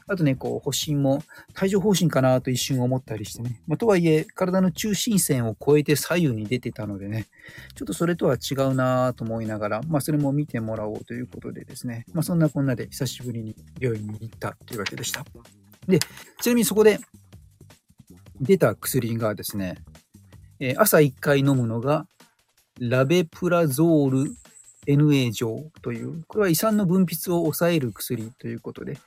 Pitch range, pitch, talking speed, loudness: 115-160 Hz, 130 Hz, 350 characters per minute, -23 LUFS